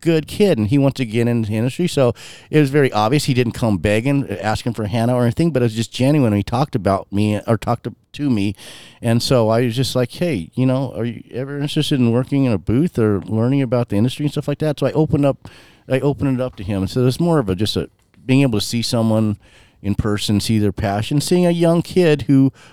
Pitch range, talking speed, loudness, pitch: 110-140 Hz, 255 wpm, -18 LUFS, 125 Hz